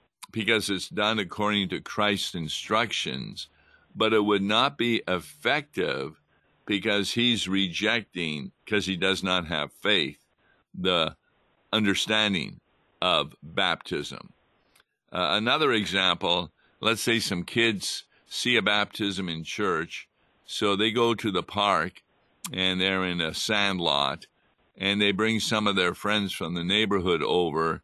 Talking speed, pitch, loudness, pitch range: 130 wpm, 100 Hz, -26 LUFS, 95-110 Hz